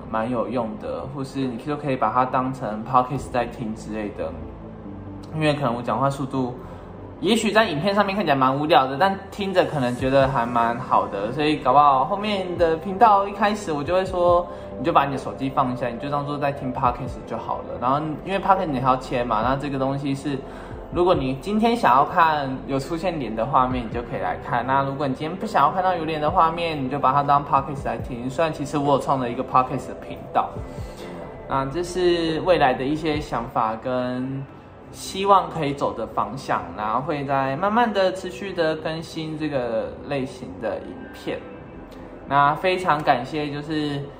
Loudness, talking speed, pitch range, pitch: -22 LUFS, 325 characters per minute, 130-165 Hz, 140 Hz